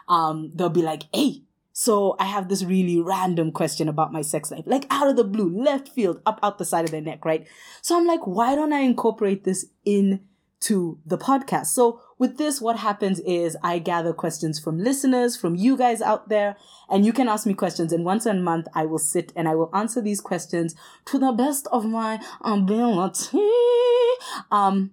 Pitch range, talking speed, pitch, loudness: 175-245 Hz, 200 wpm, 200 Hz, -23 LUFS